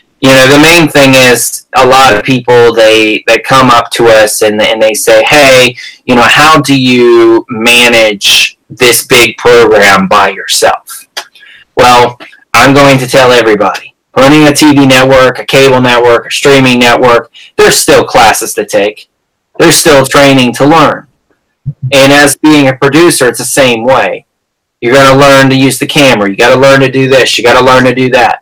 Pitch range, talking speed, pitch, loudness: 120-140 Hz, 185 wpm, 130 Hz, -4 LUFS